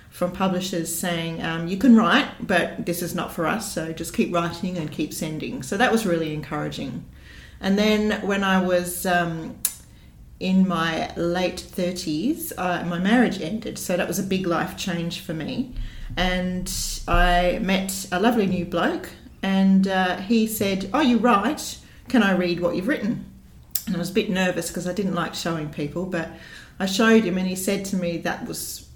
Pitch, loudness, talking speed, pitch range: 180 Hz, -23 LUFS, 190 wpm, 170-200 Hz